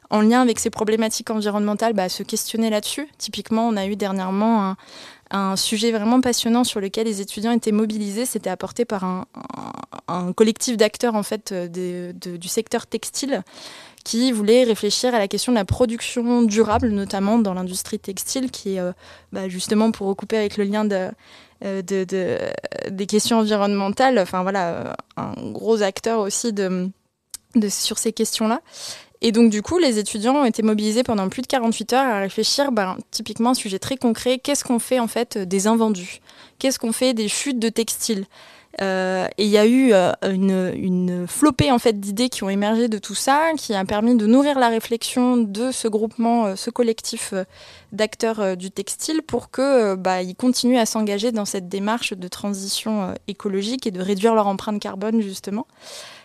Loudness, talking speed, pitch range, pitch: -21 LUFS, 185 wpm, 200-235 Hz, 220 Hz